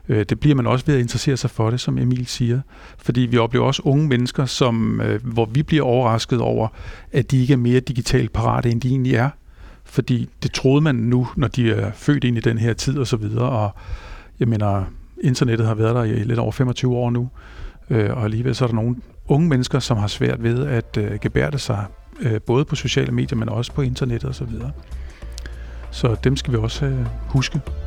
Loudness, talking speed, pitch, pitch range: -20 LUFS, 210 wpm, 120 Hz, 110-130 Hz